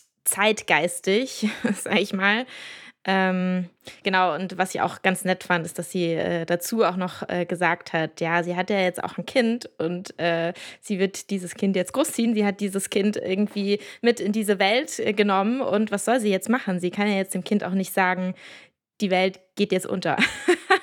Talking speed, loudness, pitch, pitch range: 200 wpm, -24 LUFS, 195 Hz, 180-215 Hz